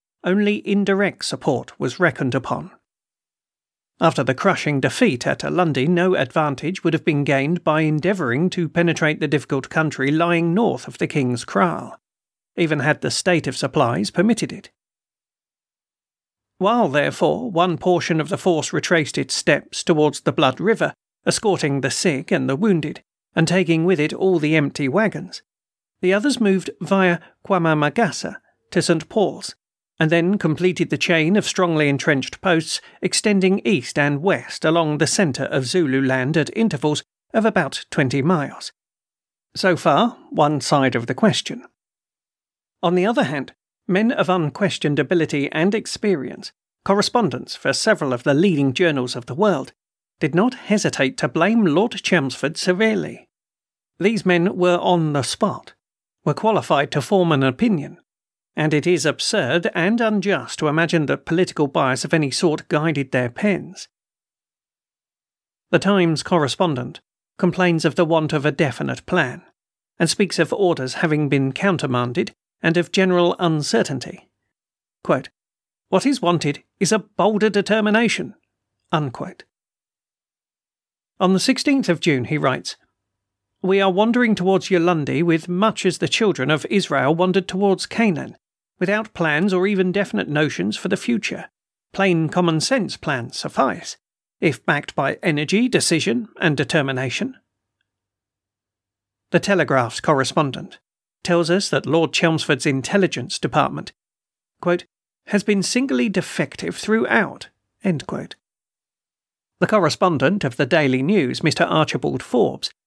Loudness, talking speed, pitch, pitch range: -19 LUFS, 140 wpm, 170 Hz, 150-190 Hz